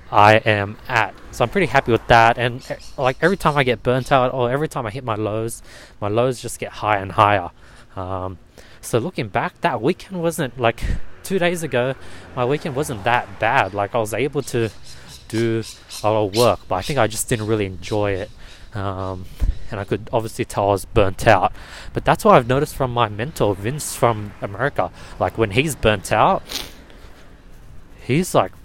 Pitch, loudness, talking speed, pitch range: 115 Hz, -20 LUFS, 195 wpm, 105-135 Hz